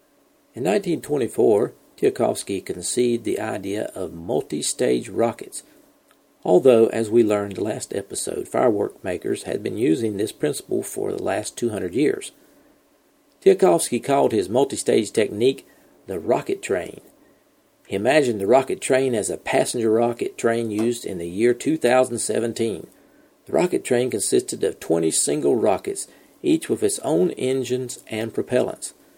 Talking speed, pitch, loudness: 135 wpm, 120 Hz, -22 LUFS